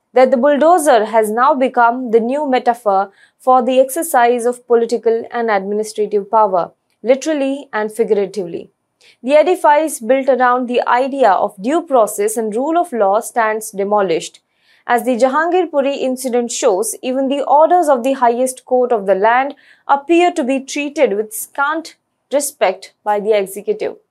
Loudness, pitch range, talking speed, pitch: -15 LUFS, 225-280 Hz, 150 wpm, 250 Hz